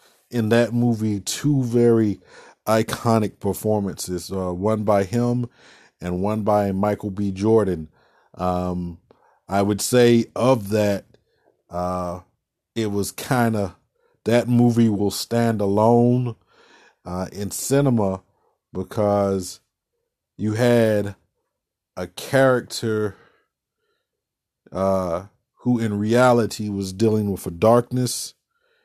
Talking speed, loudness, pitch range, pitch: 105 wpm, -21 LUFS, 95-120 Hz, 105 Hz